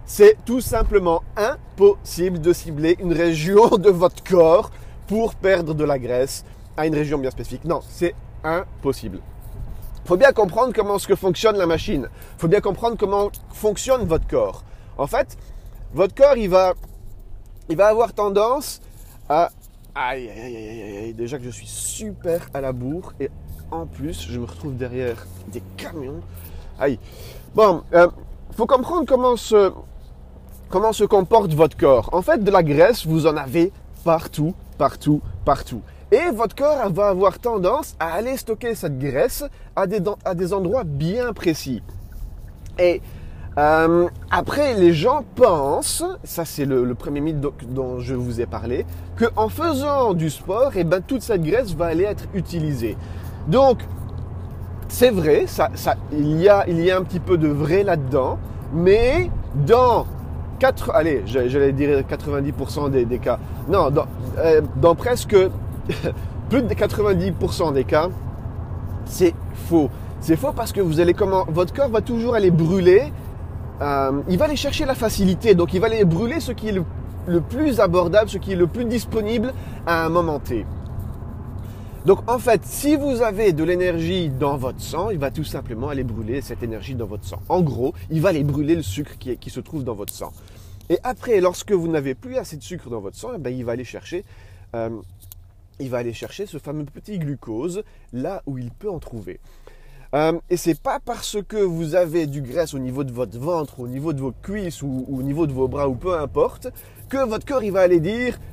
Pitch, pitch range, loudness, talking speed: 165 Hz, 125-205 Hz, -20 LUFS, 185 wpm